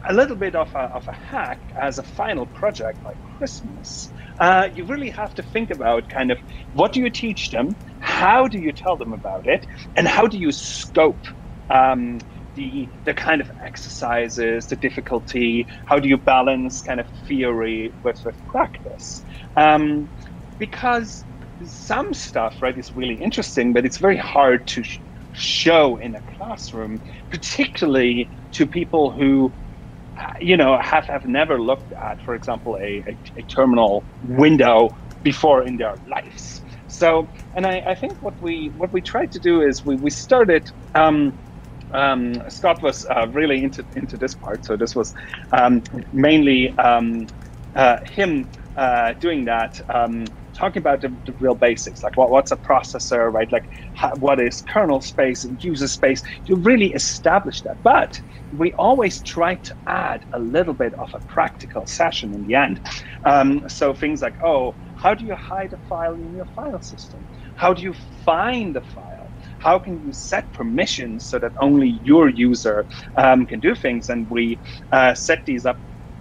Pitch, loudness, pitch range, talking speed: 135 Hz, -19 LUFS, 120-165 Hz, 170 wpm